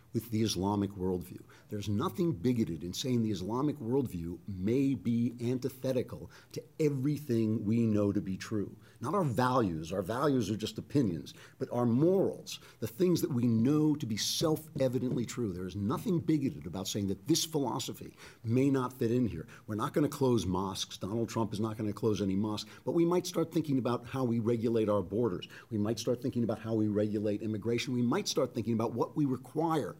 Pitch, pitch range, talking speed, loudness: 120 Hz, 105-135 Hz, 200 wpm, -32 LUFS